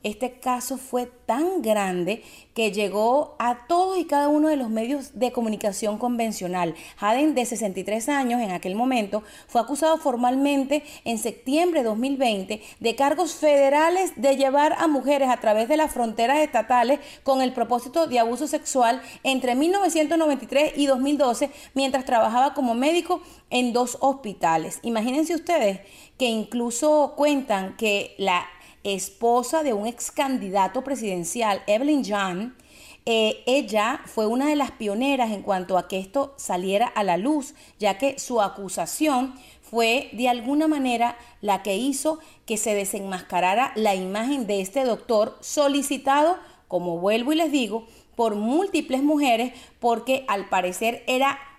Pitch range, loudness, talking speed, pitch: 215-285 Hz, -23 LUFS, 145 wpm, 250 Hz